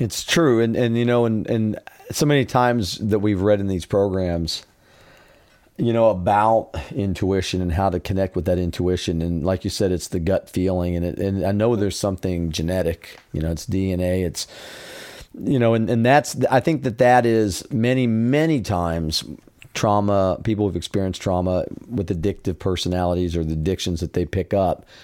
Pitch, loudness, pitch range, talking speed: 95 Hz, -21 LUFS, 90-115 Hz, 185 wpm